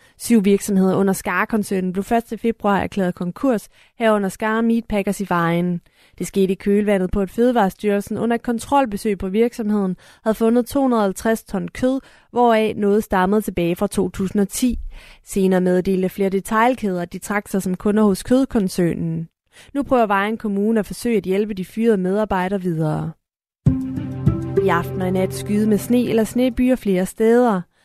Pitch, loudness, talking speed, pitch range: 205 Hz, -19 LUFS, 155 wpm, 185-225 Hz